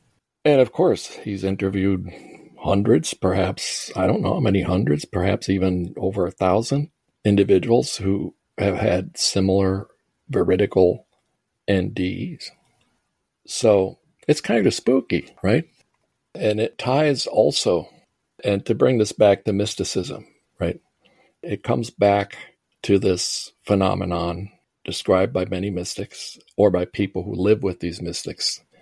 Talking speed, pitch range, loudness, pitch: 125 wpm, 95-110 Hz, -21 LUFS, 100 Hz